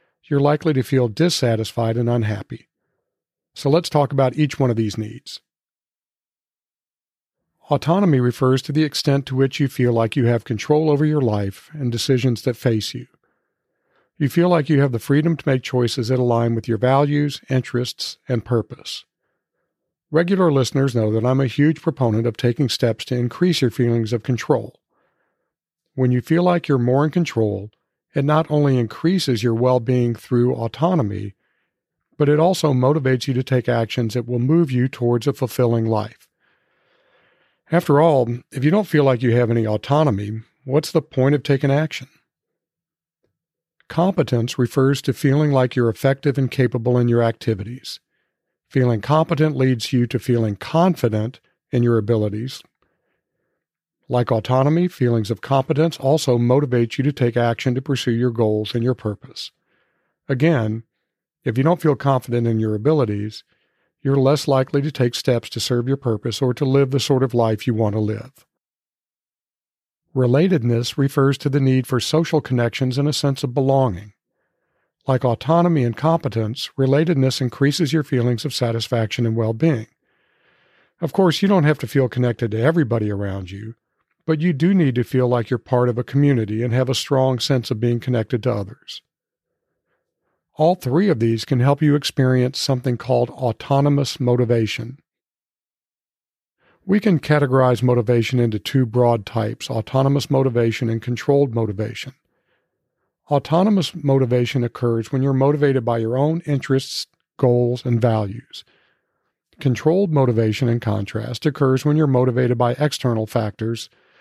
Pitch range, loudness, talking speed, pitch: 120-145 Hz, -19 LUFS, 160 wpm, 130 Hz